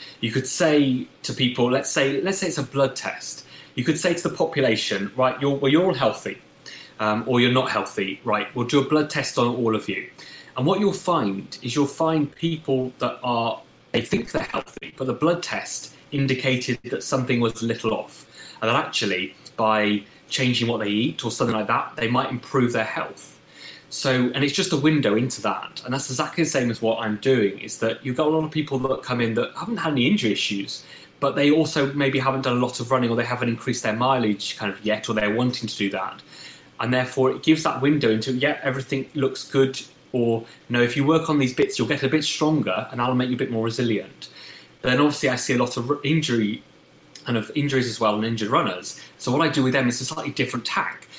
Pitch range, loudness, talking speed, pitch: 115-140 Hz, -23 LUFS, 240 wpm, 130 Hz